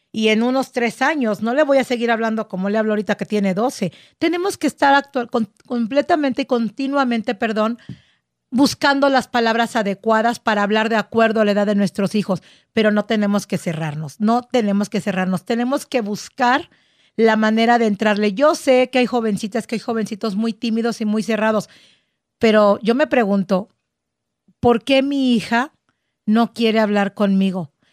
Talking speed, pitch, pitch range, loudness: 175 wpm, 225 Hz, 210-245 Hz, -18 LUFS